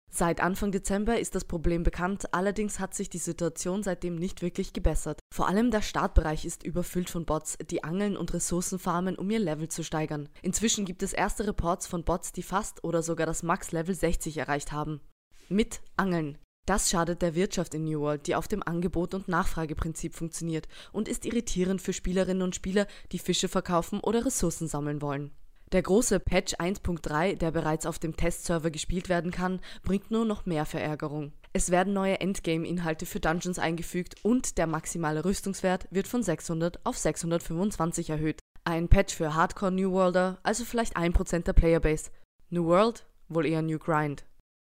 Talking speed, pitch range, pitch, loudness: 175 wpm, 165-190 Hz, 175 Hz, -30 LUFS